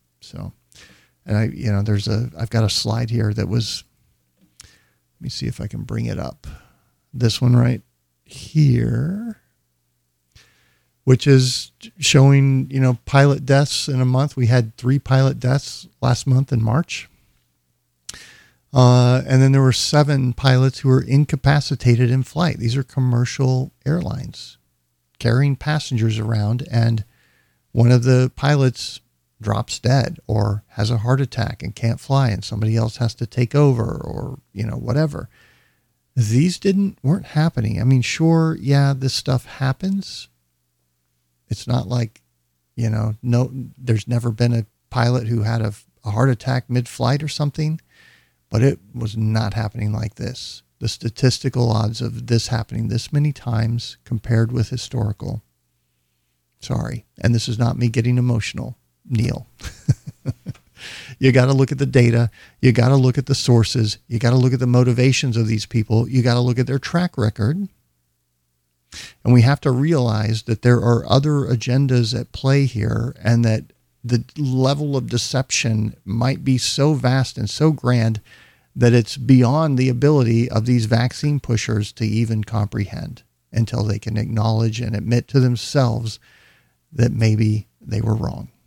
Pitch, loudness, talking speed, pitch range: 120 Hz, -19 LUFS, 160 wpm, 110-130 Hz